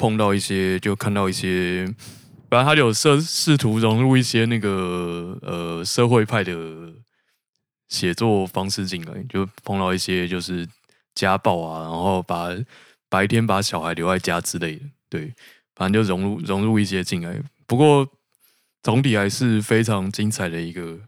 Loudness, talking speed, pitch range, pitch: -21 LUFS, 235 characters per minute, 90-115 Hz, 100 Hz